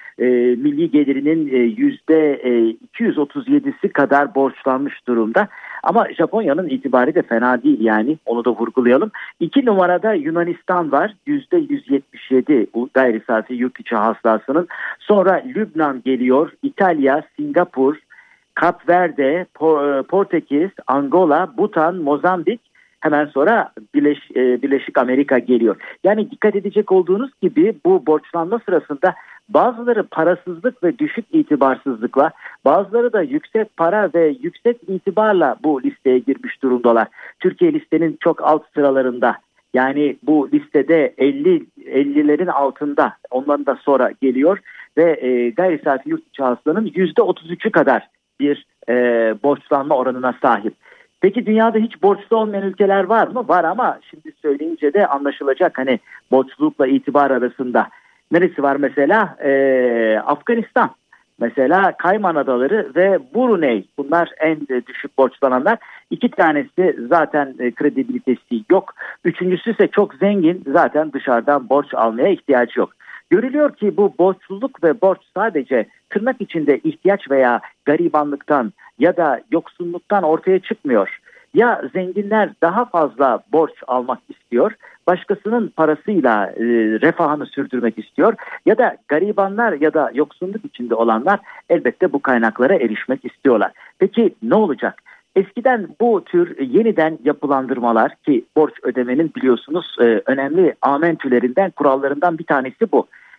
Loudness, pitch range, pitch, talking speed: -17 LUFS, 135-205 Hz, 160 Hz, 120 wpm